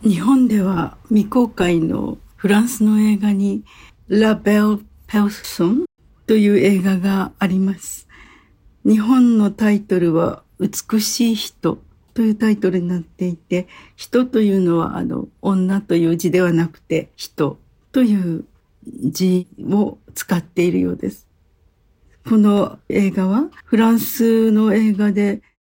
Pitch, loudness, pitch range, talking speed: 200 Hz, -18 LUFS, 180-220 Hz, 245 characters per minute